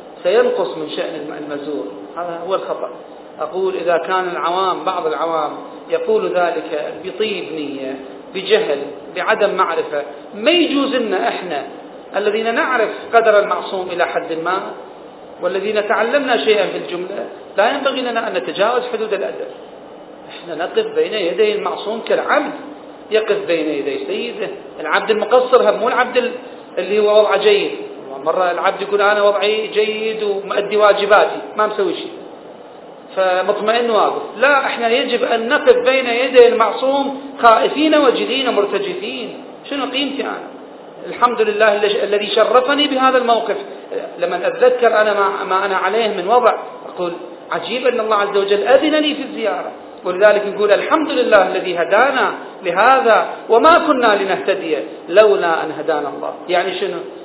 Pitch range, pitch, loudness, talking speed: 200-275 Hz, 220 Hz, -16 LUFS, 135 wpm